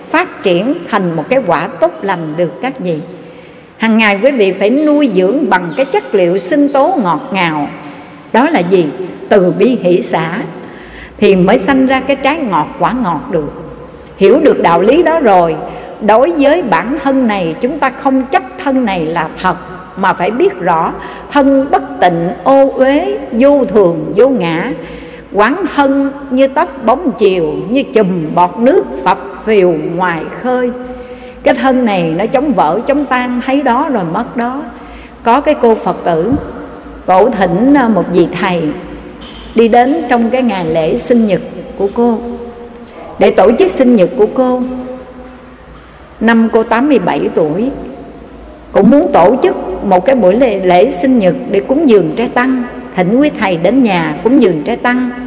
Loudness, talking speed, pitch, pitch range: -11 LUFS, 170 wpm, 240 Hz, 185-270 Hz